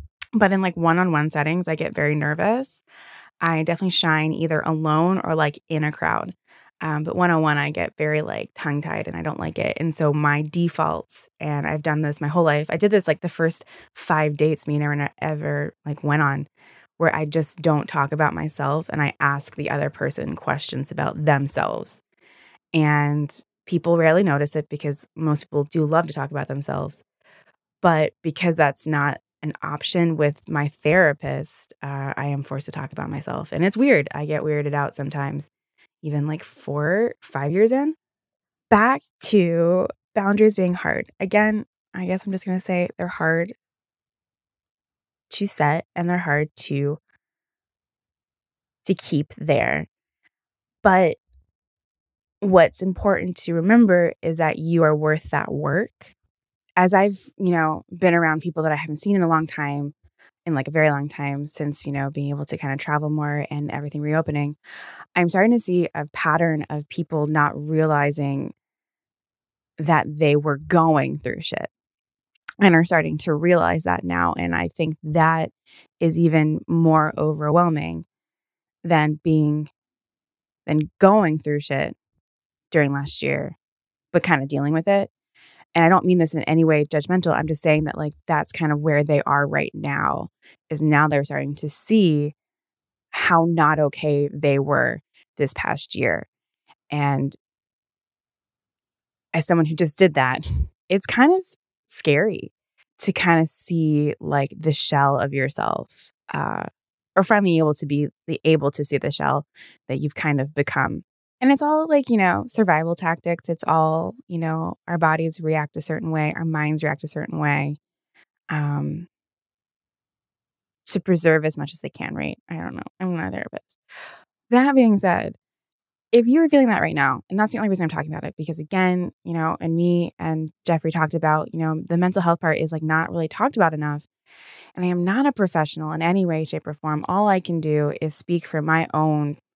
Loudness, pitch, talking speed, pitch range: -21 LUFS, 155 Hz, 180 wpm, 145-175 Hz